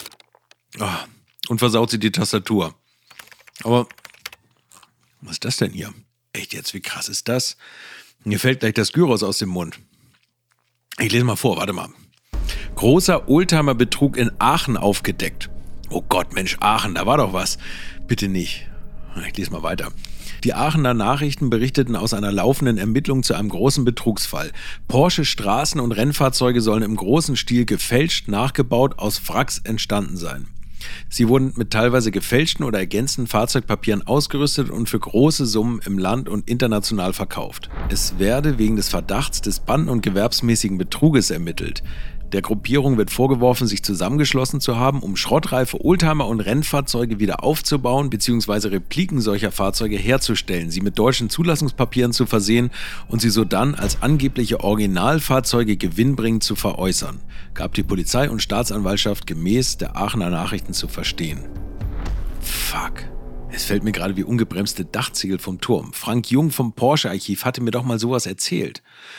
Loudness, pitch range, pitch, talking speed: -20 LUFS, 100-130 Hz, 115 Hz, 150 wpm